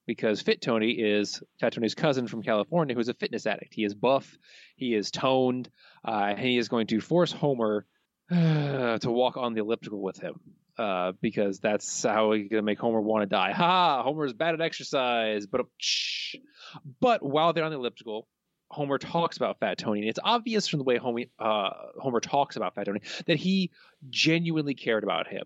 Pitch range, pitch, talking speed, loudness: 110-155 Hz, 125 Hz, 195 wpm, -27 LUFS